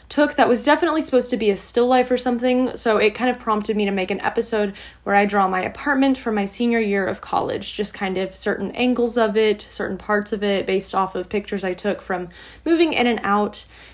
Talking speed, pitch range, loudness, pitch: 235 wpm, 200-245 Hz, -20 LUFS, 215 Hz